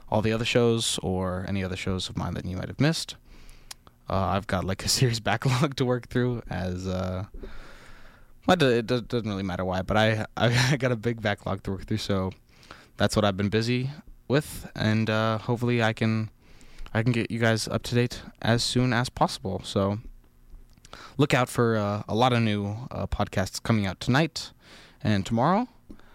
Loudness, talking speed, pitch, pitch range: -26 LUFS, 190 wpm, 110 Hz, 95-120 Hz